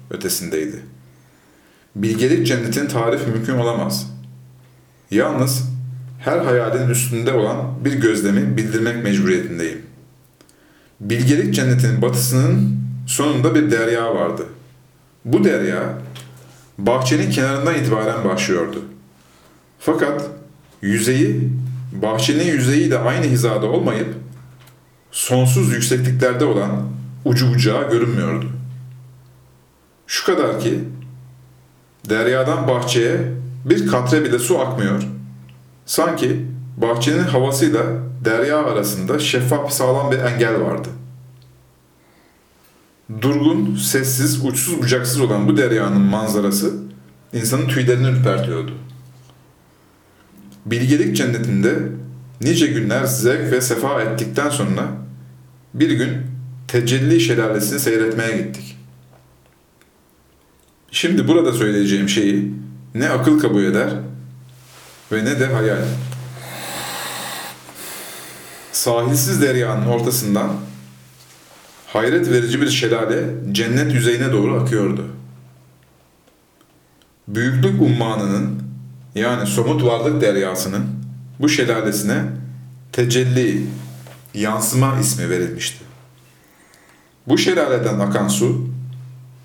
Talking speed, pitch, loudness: 85 wpm, 110 Hz, -18 LUFS